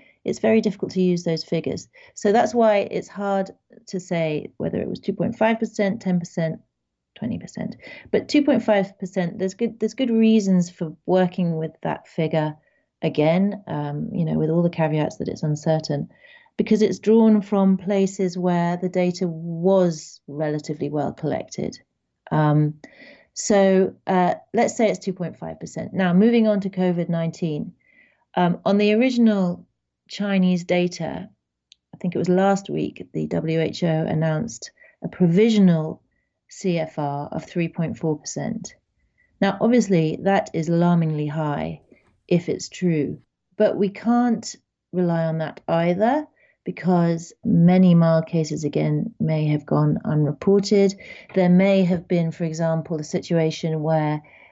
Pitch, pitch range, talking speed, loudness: 180 Hz, 160-200 Hz, 145 wpm, -22 LUFS